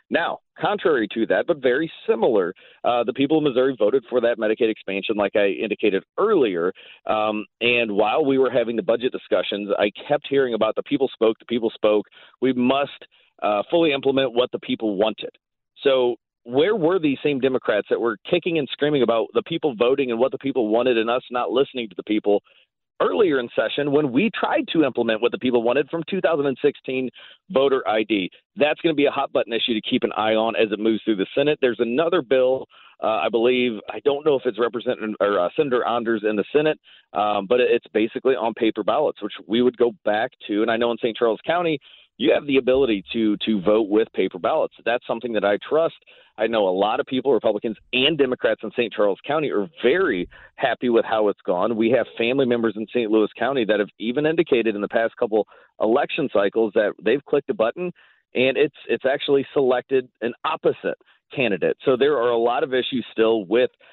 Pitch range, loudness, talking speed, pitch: 115-145 Hz, -21 LUFS, 210 wpm, 125 Hz